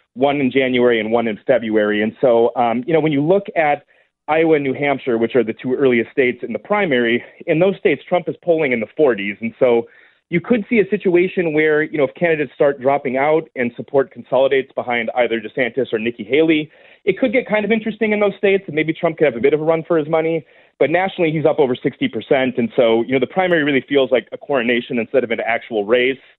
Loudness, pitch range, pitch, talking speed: -17 LUFS, 125-170 Hz, 145 Hz, 240 wpm